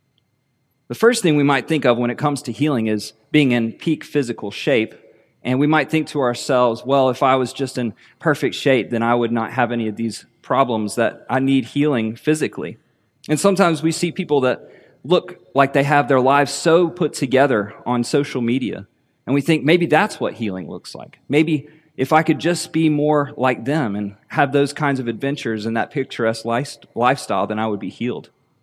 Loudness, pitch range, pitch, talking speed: -19 LUFS, 115-150 Hz, 135 Hz, 205 wpm